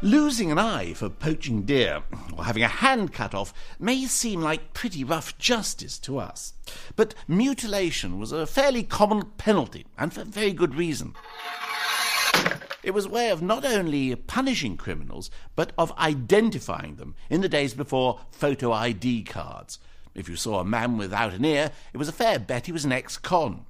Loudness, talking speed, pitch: -25 LUFS, 175 wpm, 145 Hz